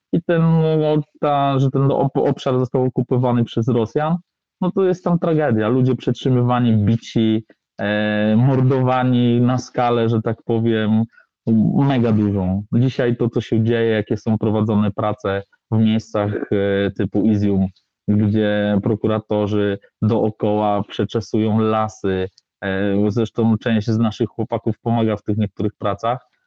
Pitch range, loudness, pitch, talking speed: 105-125 Hz, -19 LUFS, 115 Hz, 130 wpm